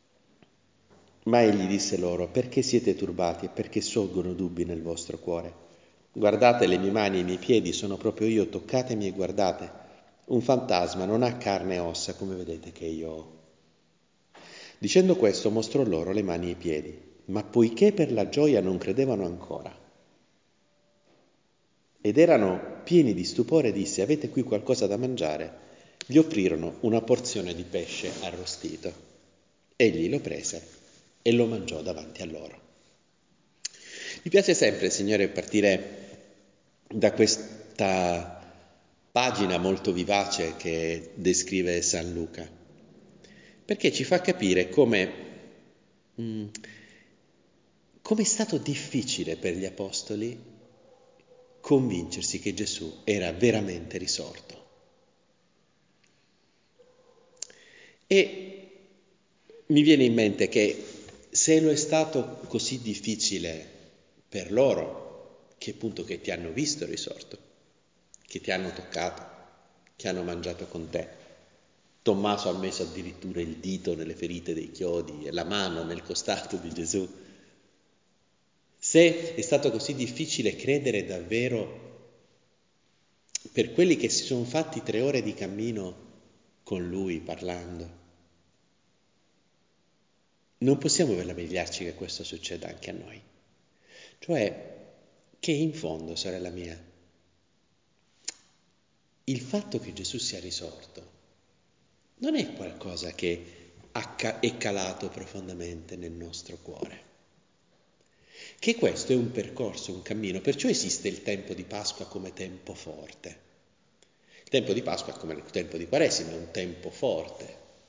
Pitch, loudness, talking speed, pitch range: 100 Hz, -27 LUFS, 125 wpm, 90-125 Hz